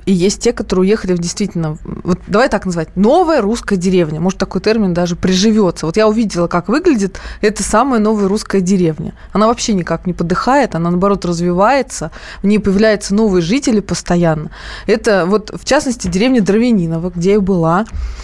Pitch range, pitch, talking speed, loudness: 180-220 Hz, 195 Hz, 170 wpm, -14 LUFS